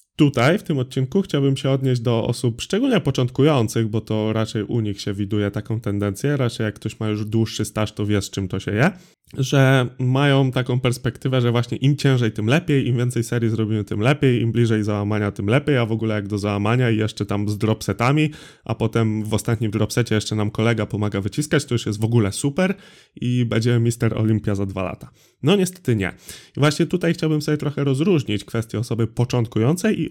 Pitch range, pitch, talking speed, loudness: 110-135 Hz, 115 Hz, 205 wpm, -21 LUFS